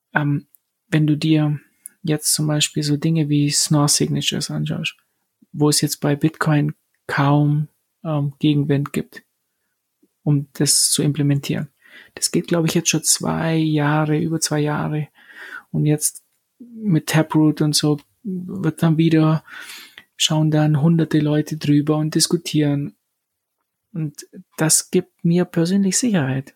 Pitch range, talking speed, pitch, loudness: 145-165 Hz, 130 wpm, 155 Hz, -19 LUFS